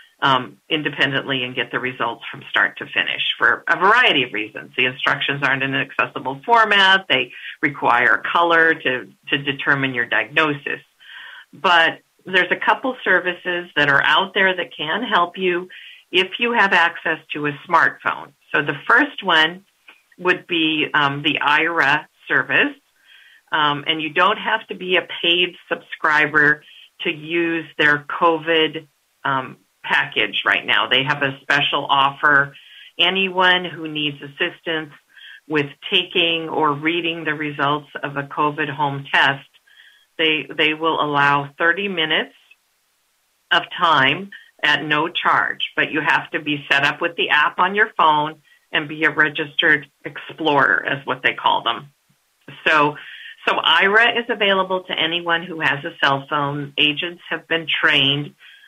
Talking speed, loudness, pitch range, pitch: 150 wpm, -18 LUFS, 145-180 Hz, 160 Hz